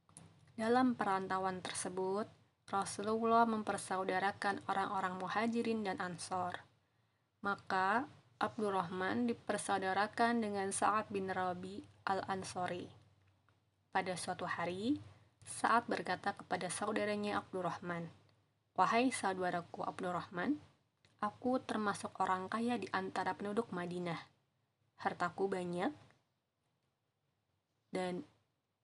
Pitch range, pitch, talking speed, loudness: 175-210 Hz, 190 Hz, 80 wpm, -38 LUFS